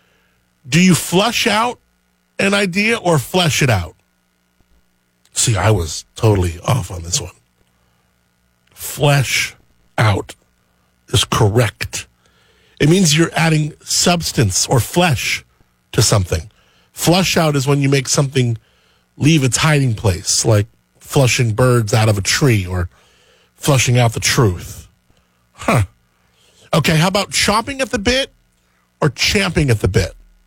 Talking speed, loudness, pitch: 130 wpm, -15 LUFS, 110 Hz